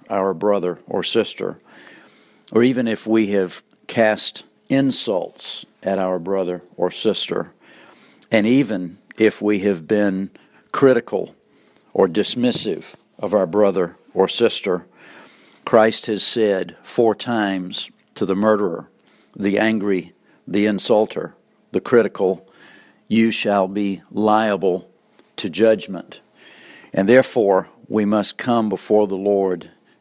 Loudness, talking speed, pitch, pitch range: -19 LUFS, 115 wpm, 105 Hz, 95-110 Hz